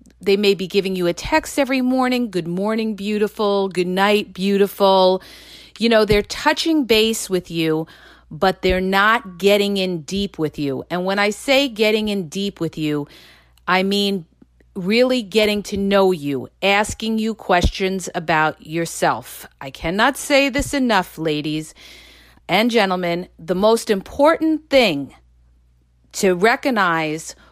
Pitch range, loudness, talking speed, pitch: 170-220 Hz, -18 LUFS, 140 wpm, 195 Hz